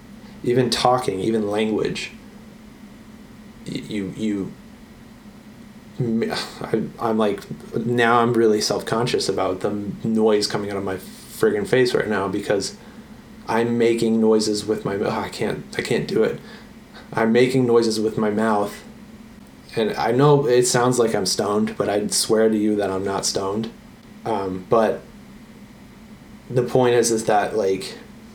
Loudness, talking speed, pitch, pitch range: -21 LUFS, 150 wpm, 115 Hz, 105-130 Hz